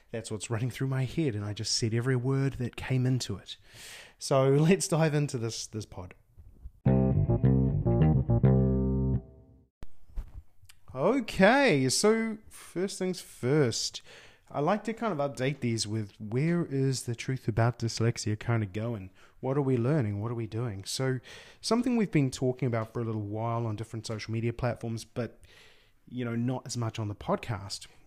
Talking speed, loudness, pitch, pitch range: 165 wpm, -29 LUFS, 120 Hz, 105-135 Hz